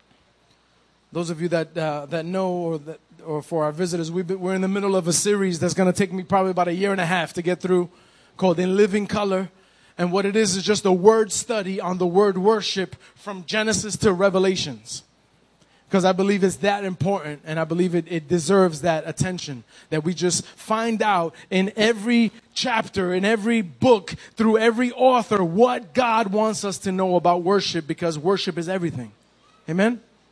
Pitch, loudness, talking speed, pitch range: 190 Hz, -22 LUFS, 195 wpm, 175-205 Hz